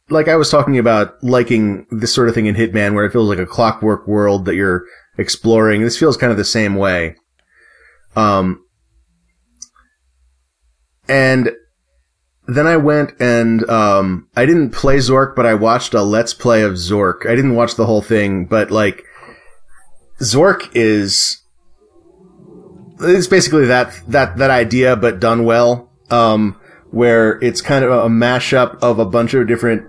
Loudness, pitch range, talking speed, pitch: -14 LUFS, 100-125 Hz, 160 wpm, 115 Hz